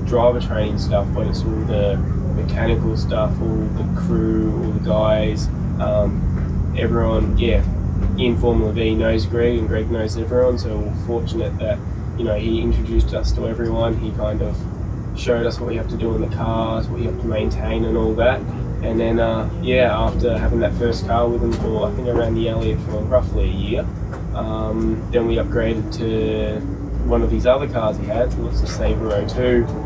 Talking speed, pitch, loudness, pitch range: 195 wpm, 110 Hz, -20 LUFS, 95-115 Hz